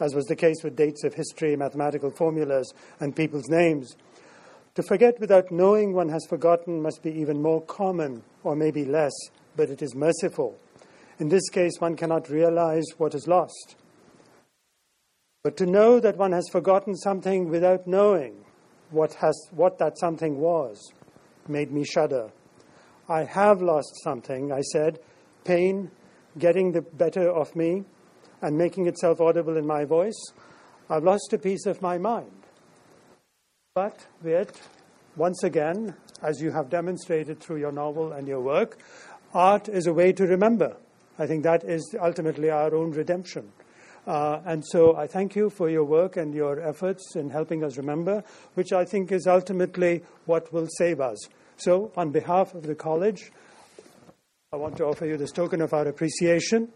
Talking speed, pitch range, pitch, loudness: 165 wpm, 155-185 Hz, 165 Hz, -25 LUFS